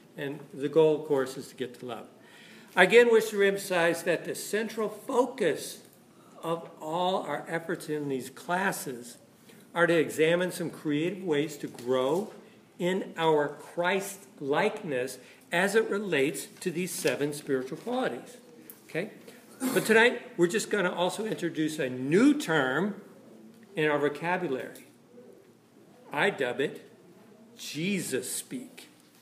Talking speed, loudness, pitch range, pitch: 135 wpm, -28 LUFS, 150-205 Hz, 175 Hz